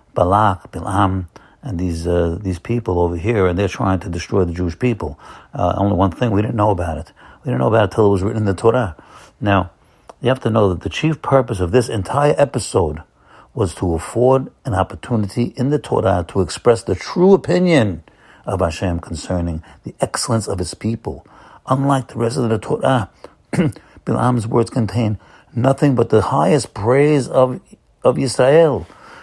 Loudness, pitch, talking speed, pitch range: -18 LUFS, 105 Hz, 185 wpm, 95-125 Hz